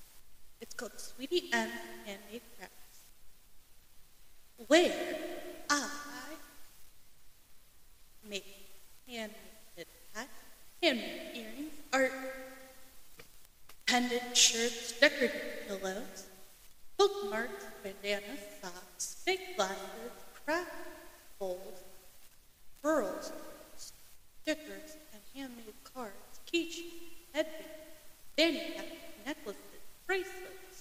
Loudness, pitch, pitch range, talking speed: -34 LUFS, 285 Hz, 220-320 Hz, 65 wpm